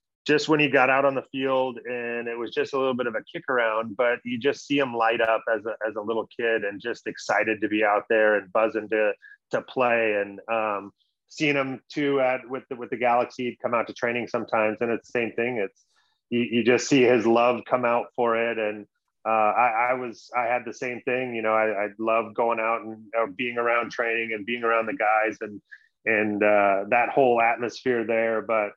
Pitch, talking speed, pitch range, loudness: 115 Hz, 230 wpm, 110-125 Hz, -24 LUFS